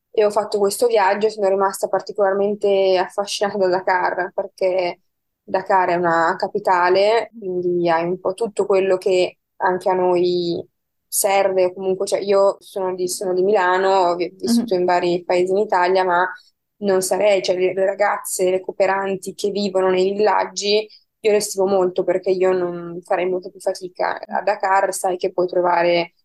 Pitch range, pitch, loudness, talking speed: 180-200 Hz, 190 Hz, -19 LUFS, 160 wpm